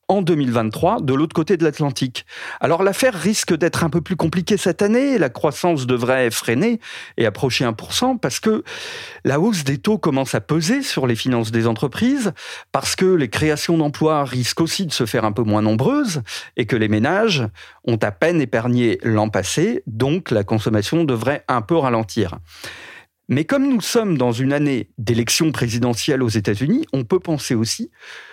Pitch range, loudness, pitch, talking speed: 120-185 Hz, -19 LUFS, 145 Hz, 180 wpm